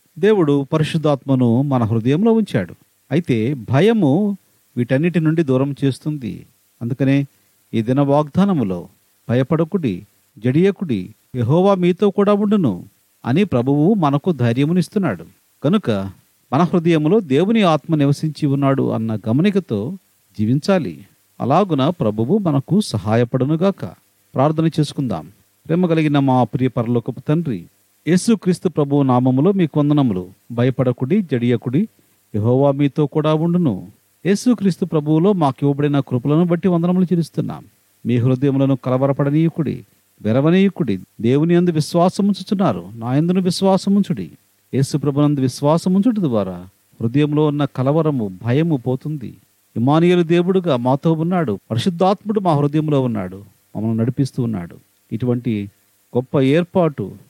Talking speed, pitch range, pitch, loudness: 100 wpm, 120-175 Hz, 145 Hz, -18 LUFS